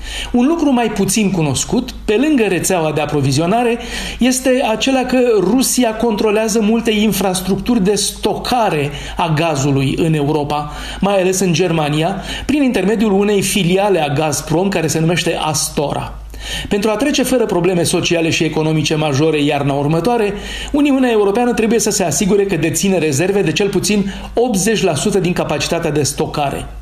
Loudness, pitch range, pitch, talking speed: -15 LUFS, 160-225 Hz, 195 Hz, 145 wpm